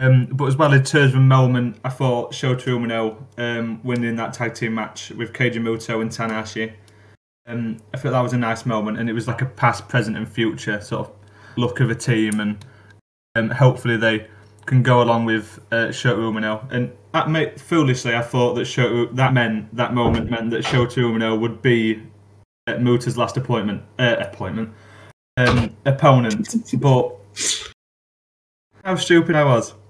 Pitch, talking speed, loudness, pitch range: 115 Hz, 180 wpm, -20 LUFS, 110-125 Hz